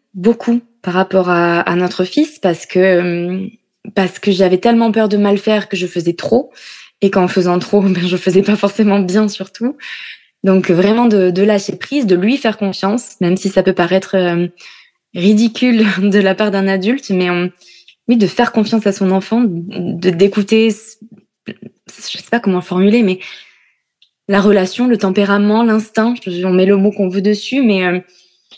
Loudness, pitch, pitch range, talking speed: -14 LUFS, 195 Hz, 185-220 Hz, 180 wpm